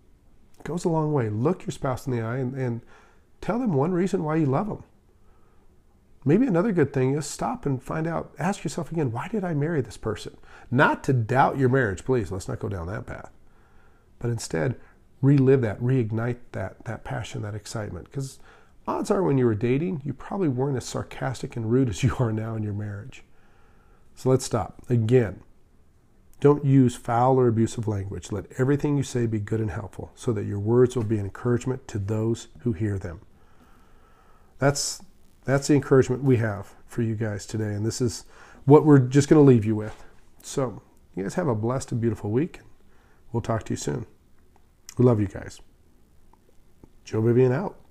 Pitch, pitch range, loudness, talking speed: 120 Hz, 105-135 Hz, -25 LUFS, 195 wpm